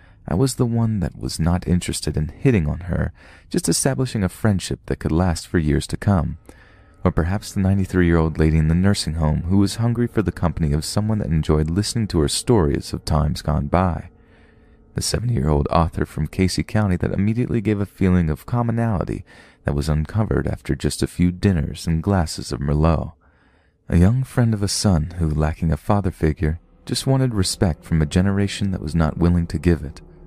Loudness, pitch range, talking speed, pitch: -21 LUFS, 80-100 Hz, 205 wpm, 85 Hz